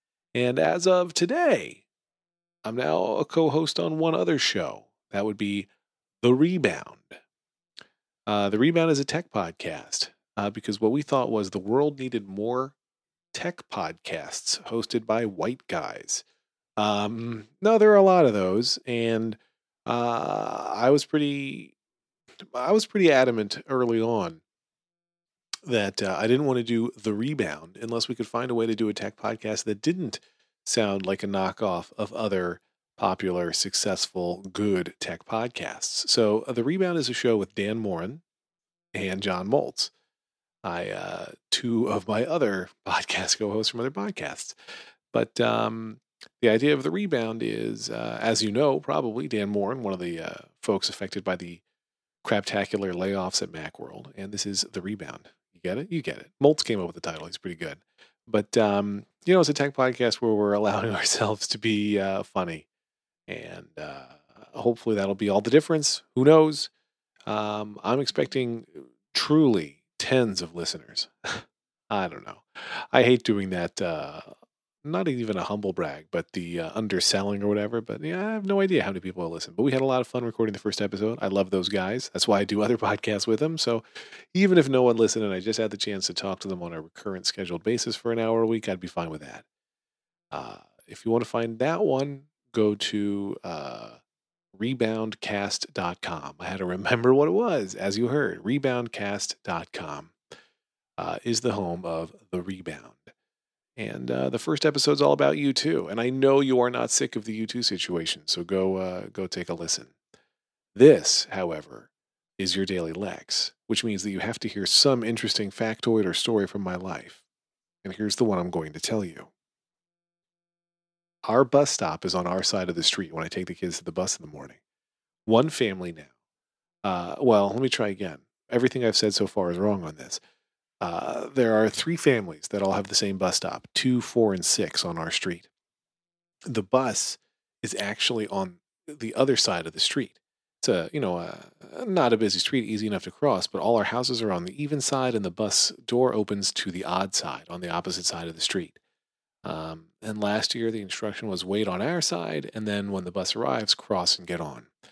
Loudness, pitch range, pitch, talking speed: -26 LUFS, 100-130 Hz, 110 Hz, 190 wpm